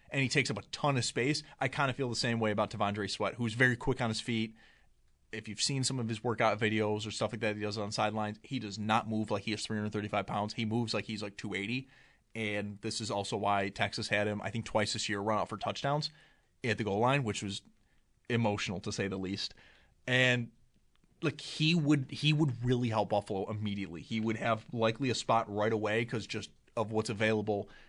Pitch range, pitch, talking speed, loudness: 105-125 Hz, 110 Hz, 230 wpm, -33 LUFS